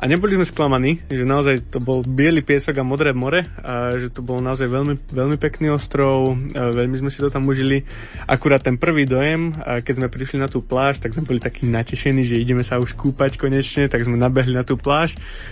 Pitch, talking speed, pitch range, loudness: 135 Hz, 215 wpm, 125-140 Hz, -19 LUFS